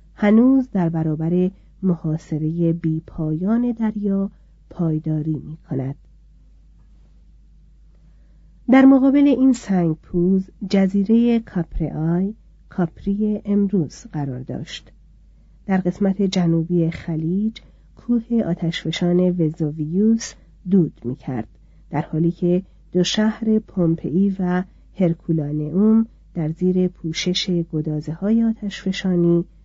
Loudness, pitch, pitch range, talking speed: -20 LUFS, 180 Hz, 160-200 Hz, 90 wpm